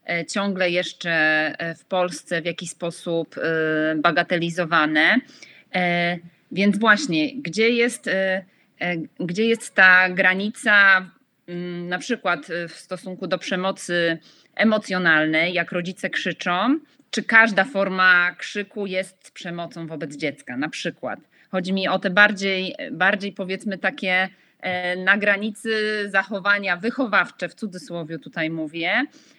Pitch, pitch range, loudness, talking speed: 185 Hz, 175-205 Hz, -21 LUFS, 105 wpm